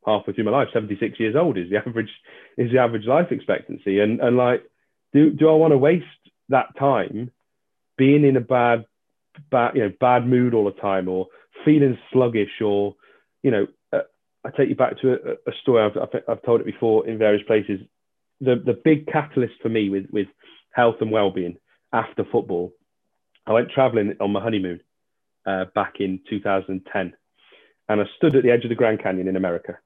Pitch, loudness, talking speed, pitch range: 115 Hz, -21 LUFS, 195 wpm, 100-125 Hz